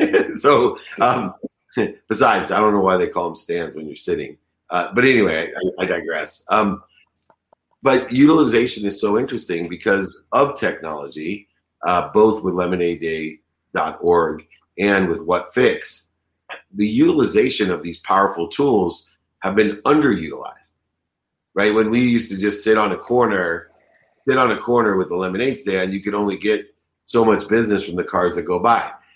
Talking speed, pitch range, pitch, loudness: 155 wpm, 90-110 Hz, 100 Hz, -19 LUFS